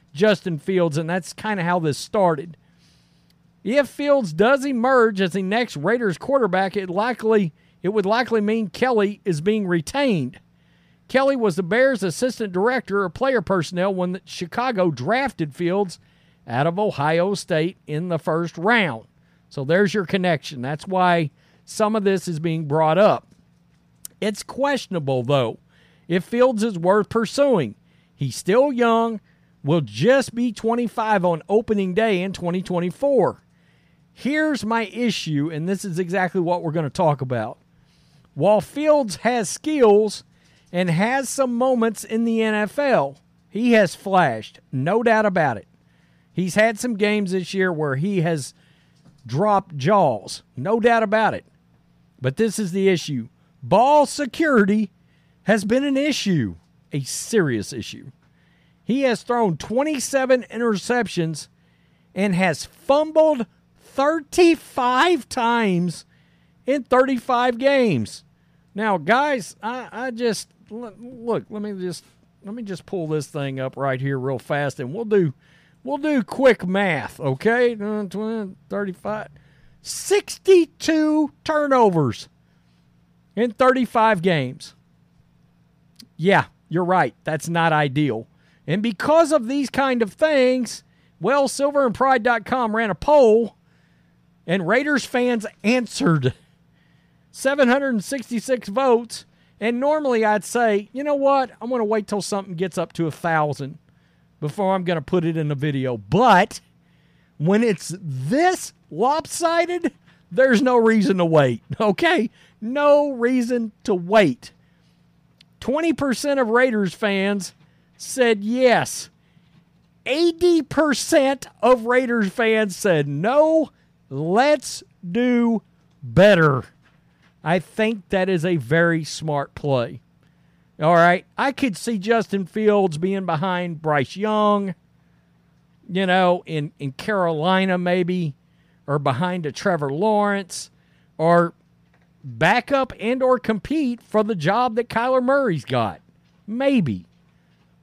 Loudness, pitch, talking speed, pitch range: -20 LUFS, 200 Hz, 125 wpm, 165-240 Hz